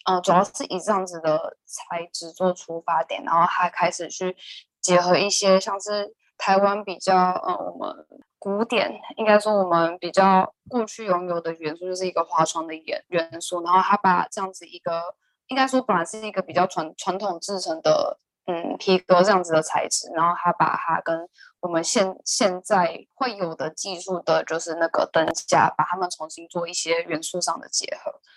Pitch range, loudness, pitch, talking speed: 165-195 Hz, -23 LUFS, 180 Hz, 280 characters per minute